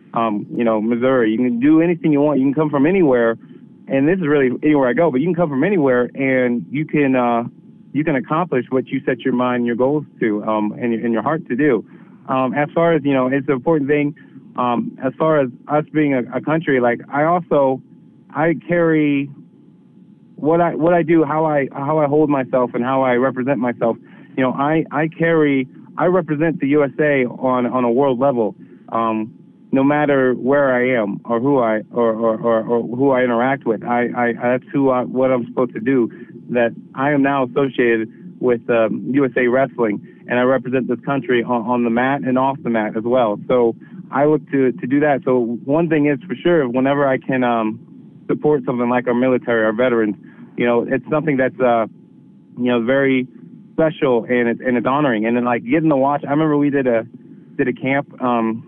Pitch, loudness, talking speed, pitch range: 130 Hz, -18 LUFS, 215 wpm, 120-145 Hz